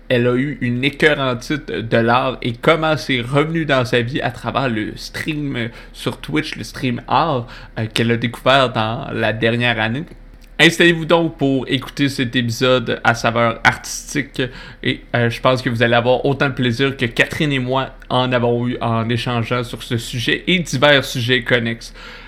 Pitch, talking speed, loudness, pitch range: 125 Hz, 180 wpm, -17 LUFS, 120-140 Hz